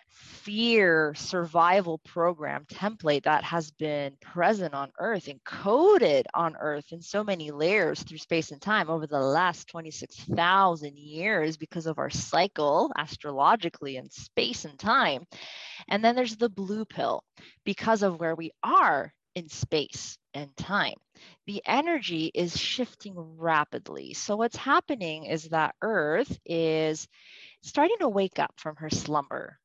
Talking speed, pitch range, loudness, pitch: 140 wpm, 155-205 Hz, -27 LUFS, 165 Hz